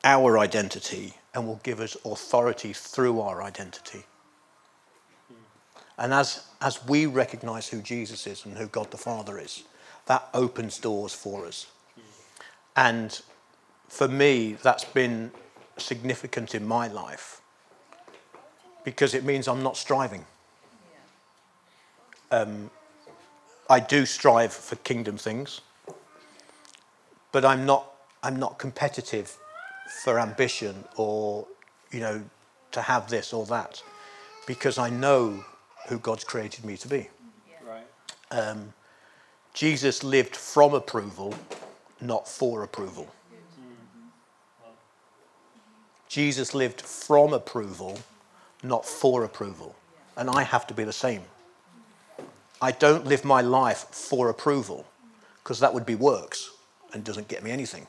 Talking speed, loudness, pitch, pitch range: 120 wpm, -26 LUFS, 130 Hz, 110-140 Hz